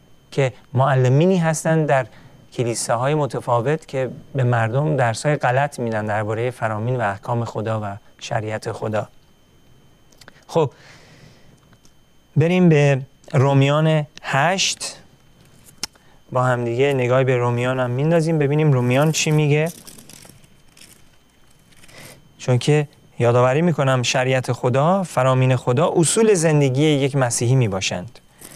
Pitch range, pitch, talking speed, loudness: 125-150 Hz, 135 Hz, 105 wpm, -19 LUFS